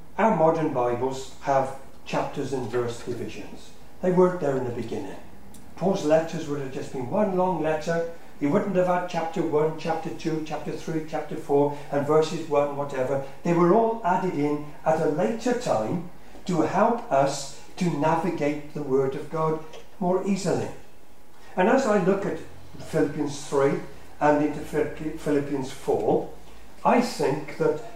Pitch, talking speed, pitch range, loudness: 155 Hz, 155 wpm, 145-170 Hz, -25 LUFS